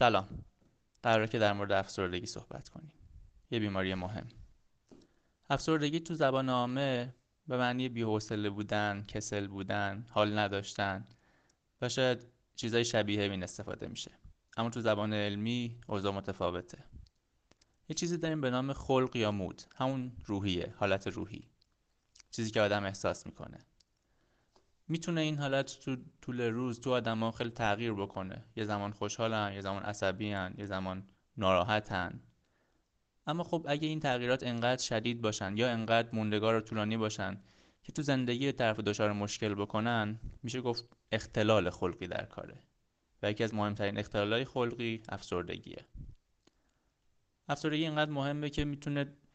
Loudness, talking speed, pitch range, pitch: -34 LUFS, 135 wpm, 100-125 Hz, 110 Hz